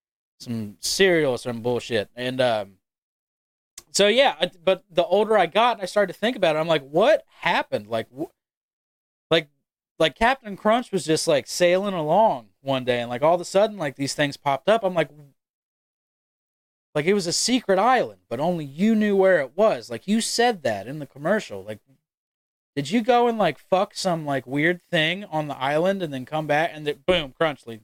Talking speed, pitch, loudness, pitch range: 200 wpm, 165 Hz, -22 LUFS, 140-200 Hz